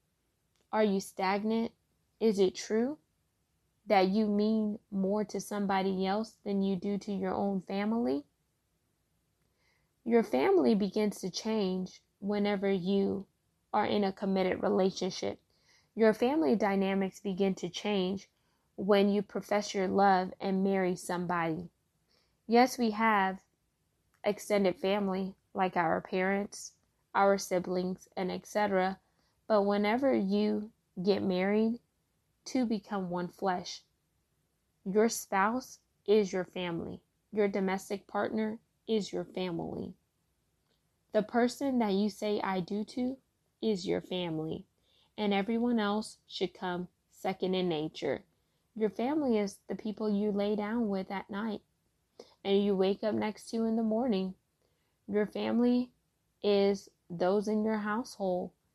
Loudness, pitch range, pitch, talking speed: -32 LUFS, 190-215 Hz, 200 Hz, 130 wpm